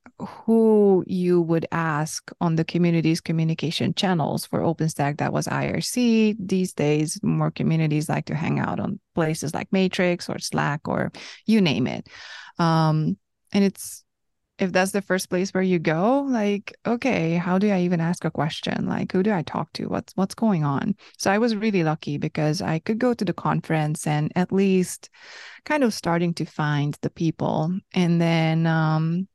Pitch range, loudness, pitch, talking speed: 160-200 Hz, -23 LUFS, 175 Hz, 180 wpm